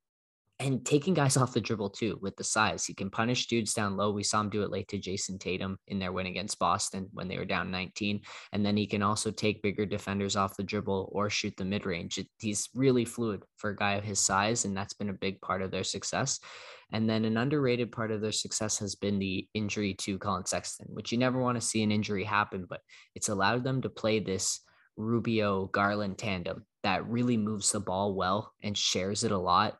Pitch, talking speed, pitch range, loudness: 105 Hz, 230 wpm, 95-110 Hz, -31 LUFS